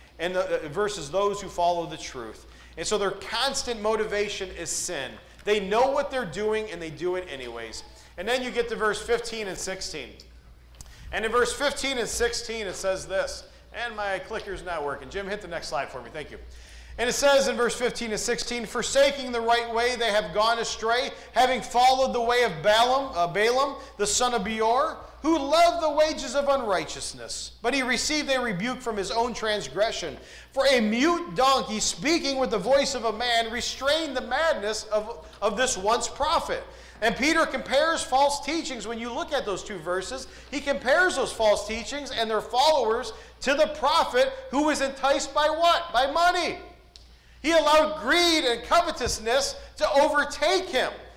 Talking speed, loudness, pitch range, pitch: 185 wpm, -25 LUFS, 210-280 Hz, 240 Hz